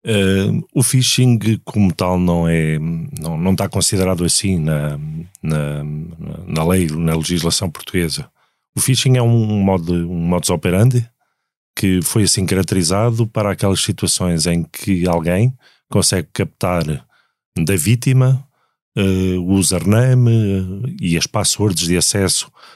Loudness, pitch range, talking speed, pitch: -16 LUFS, 85-110 Hz, 130 wpm, 95 Hz